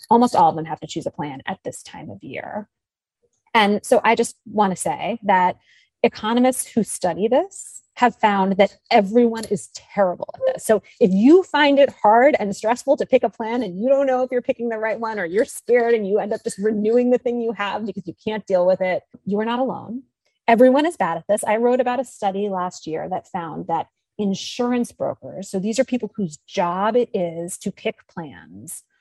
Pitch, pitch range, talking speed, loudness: 220 Hz, 200-245 Hz, 220 wpm, -20 LUFS